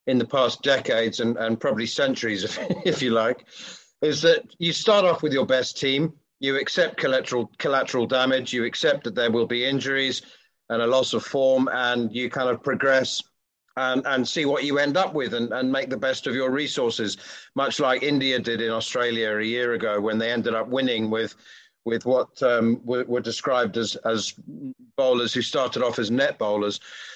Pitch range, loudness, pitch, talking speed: 115-135 Hz, -23 LUFS, 125 Hz, 195 wpm